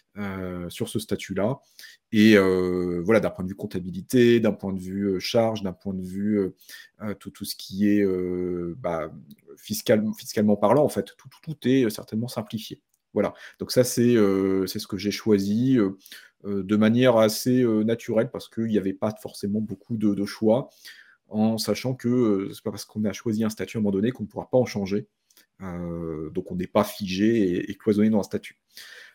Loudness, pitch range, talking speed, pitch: -24 LUFS, 95-115 Hz, 210 wpm, 105 Hz